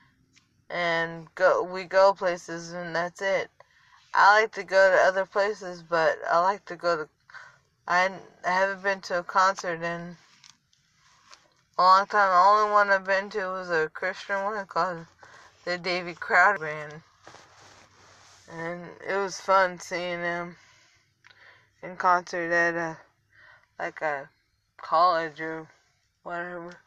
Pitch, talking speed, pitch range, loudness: 175 Hz, 140 wpm, 165-195 Hz, -25 LUFS